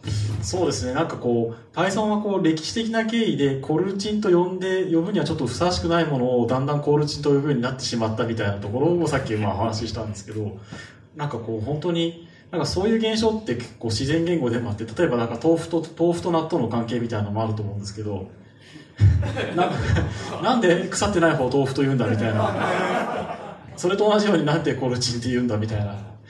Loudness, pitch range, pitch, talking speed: -23 LUFS, 110-170 Hz, 130 Hz, 465 characters per minute